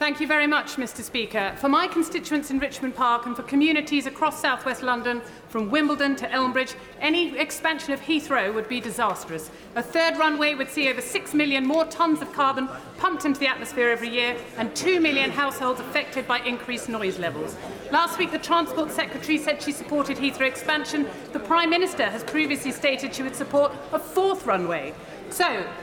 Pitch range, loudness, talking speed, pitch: 250-310 Hz, -24 LUFS, 185 wpm, 280 Hz